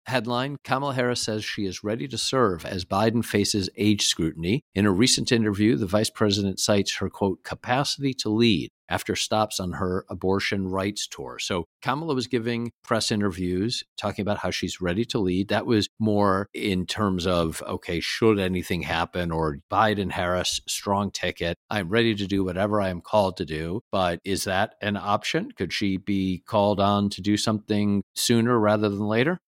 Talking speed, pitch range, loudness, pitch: 180 wpm, 95-110 Hz, -25 LUFS, 105 Hz